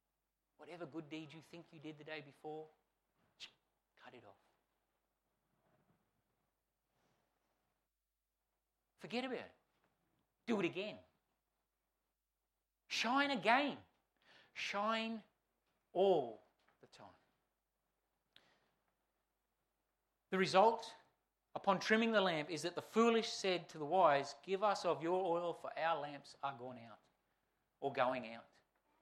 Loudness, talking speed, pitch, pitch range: -38 LUFS, 110 wpm, 170 Hz, 140-210 Hz